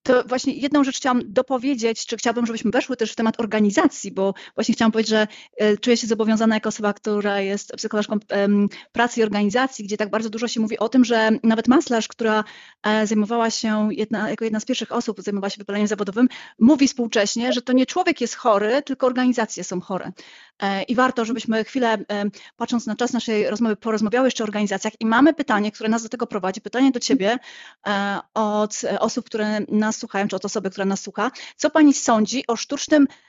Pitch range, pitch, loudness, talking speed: 210-245 Hz, 225 Hz, -21 LUFS, 190 wpm